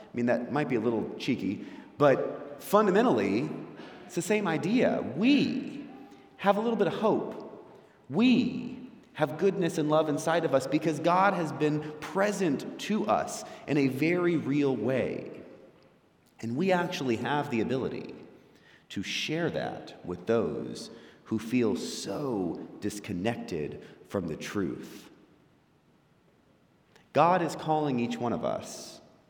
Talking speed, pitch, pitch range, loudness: 135 wpm, 160 Hz, 135-200 Hz, -29 LUFS